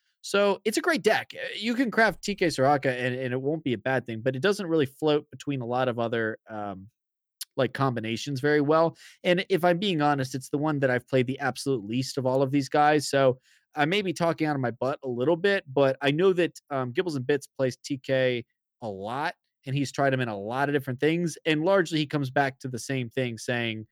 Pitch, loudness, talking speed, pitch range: 140 Hz, -26 LUFS, 240 wpm, 130-160 Hz